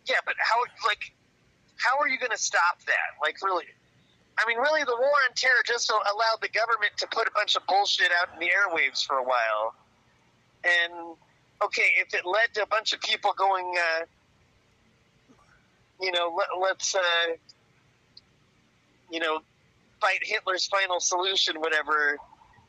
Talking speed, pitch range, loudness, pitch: 160 wpm, 150-210 Hz, -25 LUFS, 175 Hz